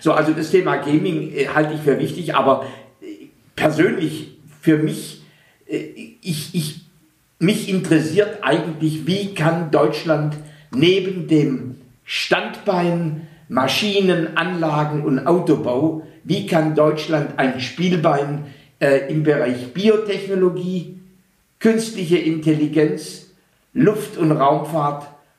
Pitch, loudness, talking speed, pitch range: 160 Hz, -19 LUFS, 105 wpm, 150-180 Hz